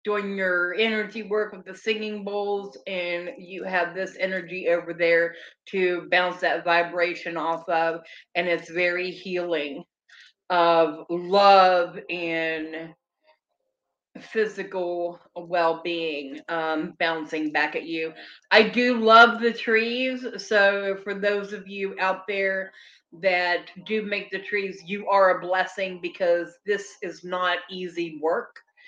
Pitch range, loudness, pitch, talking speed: 170-205 Hz, -24 LUFS, 185 Hz, 130 wpm